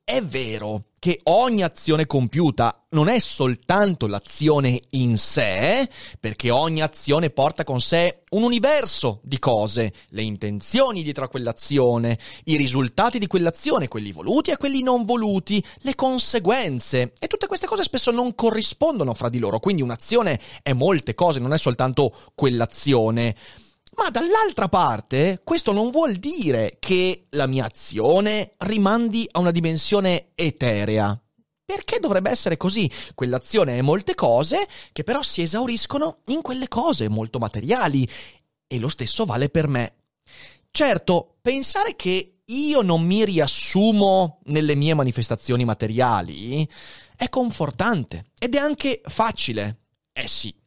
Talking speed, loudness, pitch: 135 wpm, -21 LUFS, 160 Hz